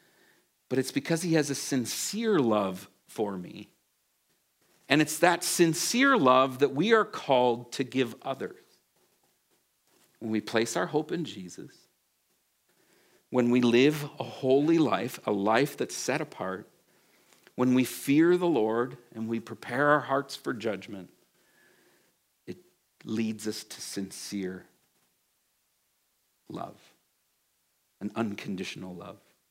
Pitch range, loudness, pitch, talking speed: 110-150 Hz, -28 LUFS, 130 Hz, 125 wpm